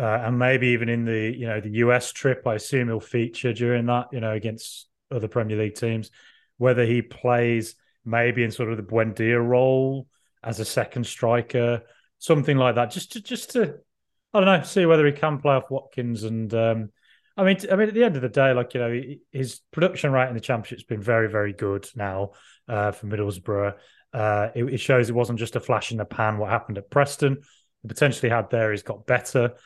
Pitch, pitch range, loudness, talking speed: 120 Hz, 110-130 Hz, -23 LUFS, 215 wpm